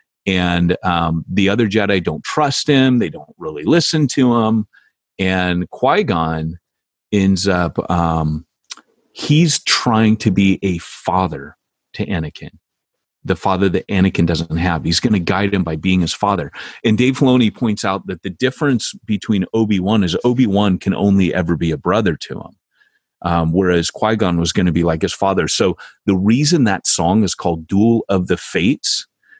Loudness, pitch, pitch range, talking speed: -16 LUFS, 95 Hz, 85-110 Hz, 180 wpm